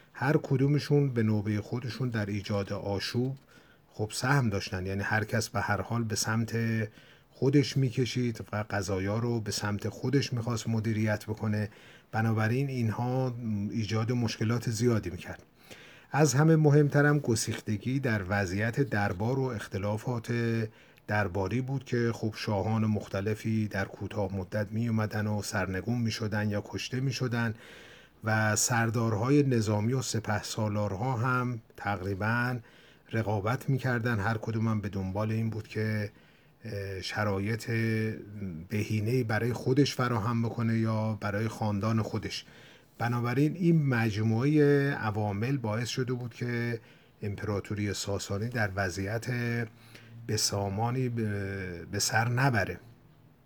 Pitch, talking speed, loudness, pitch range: 115 Hz, 115 wpm, -30 LUFS, 105-120 Hz